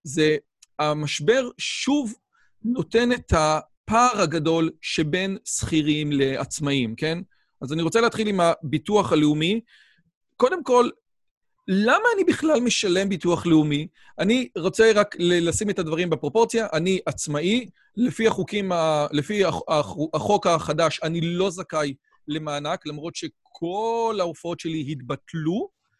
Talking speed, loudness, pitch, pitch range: 115 wpm, -23 LUFS, 170 Hz, 155-215 Hz